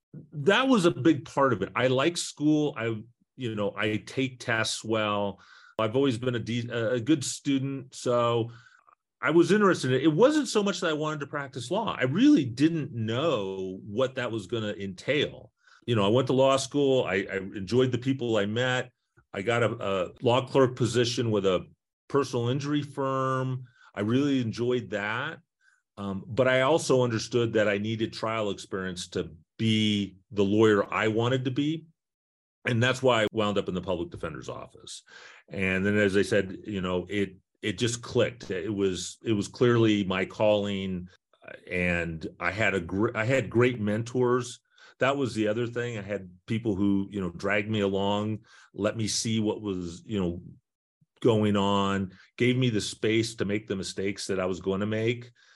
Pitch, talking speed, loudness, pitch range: 115 Hz, 190 wpm, -27 LUFS, 100-130 Hz